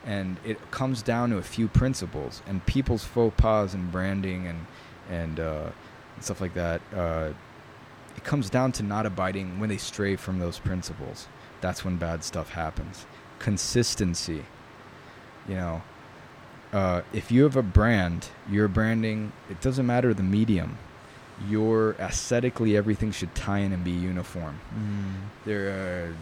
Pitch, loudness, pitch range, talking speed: 100 Hz, -28 LUFS, 90-115 Hz, 155 wpm